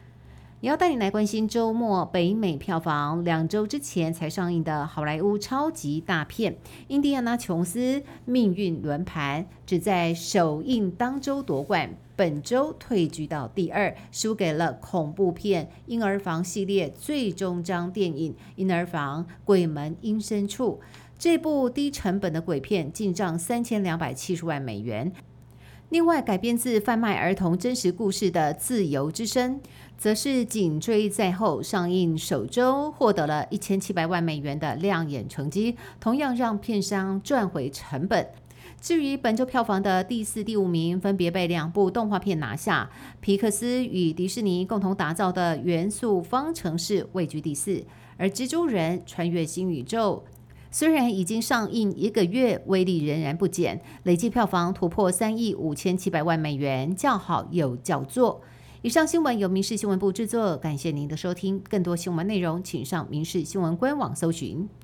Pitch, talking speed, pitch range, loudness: 190 Hz, 250 characters per minute, 165-220 Hz, -26 LUFS